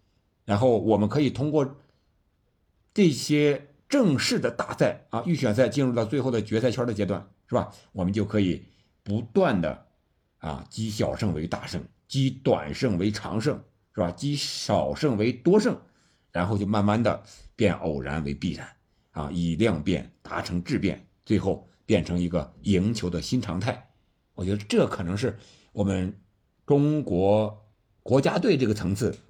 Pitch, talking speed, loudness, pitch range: 105 Hz, 230 characters per minute, -26 LUFS, 95-130 Hz